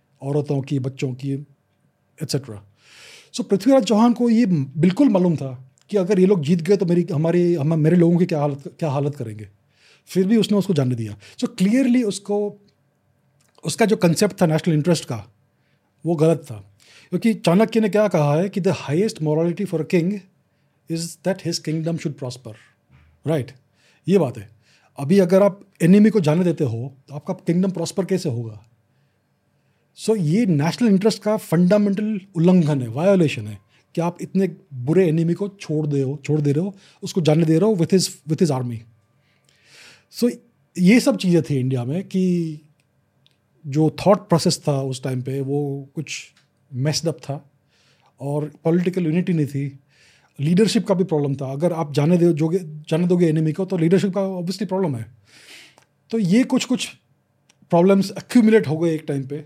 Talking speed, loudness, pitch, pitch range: 175 wpm, -20 LUFS, 165 Hz, 140-190 Hz